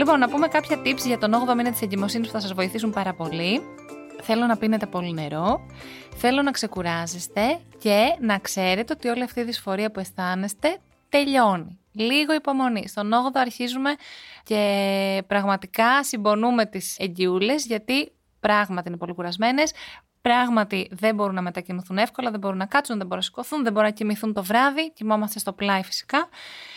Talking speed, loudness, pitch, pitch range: 170 wpm, -23 LUFS, 215 Hz, 195-245 Hz